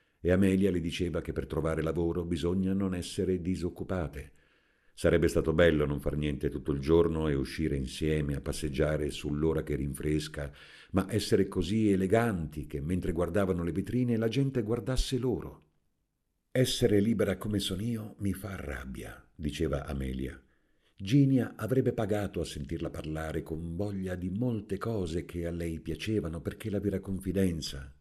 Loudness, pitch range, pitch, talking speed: -31 LUFS, 75-100 Hz, 85 Hz, 150 wpm